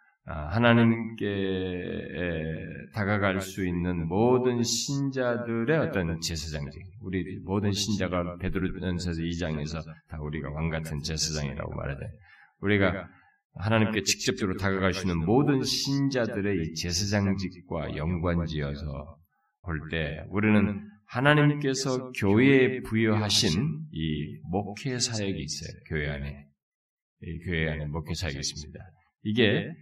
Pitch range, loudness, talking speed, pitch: 80-110 Hz, -28 LUFS, 280 characters per minute, 95 Hz